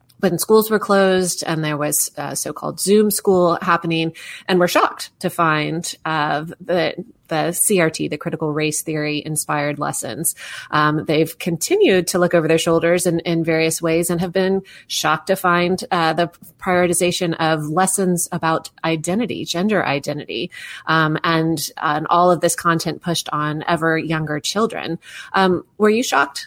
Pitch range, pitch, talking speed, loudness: 160-180 Hz, 170 Hz, 160 wpm, -18 LUFS